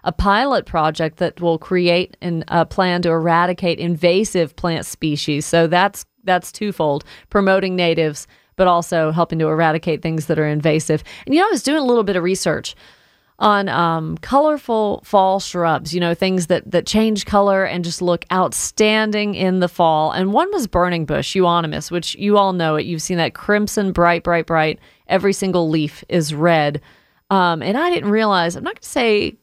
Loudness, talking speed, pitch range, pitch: -18 LUFS, 190 wpm, 165-200 Hz, 175 Hz